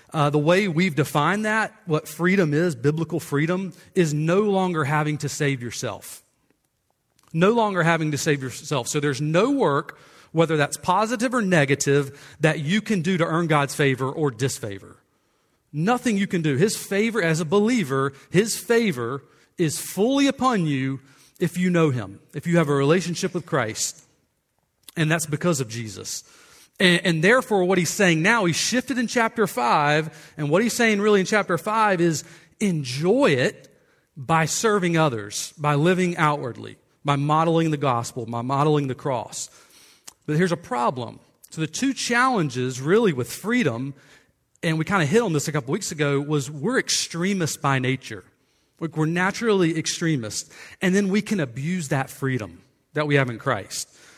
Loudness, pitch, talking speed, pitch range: -22 LUFS, 160 Hz, 170 wpm, 140-190 Hz